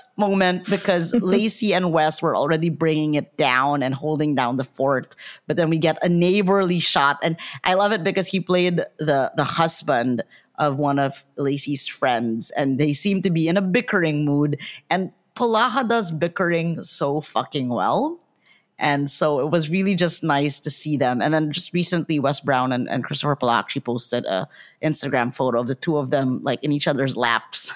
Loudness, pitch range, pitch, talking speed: -20 LUFS, 140-180 Hz, 155 Hz, 190 wpm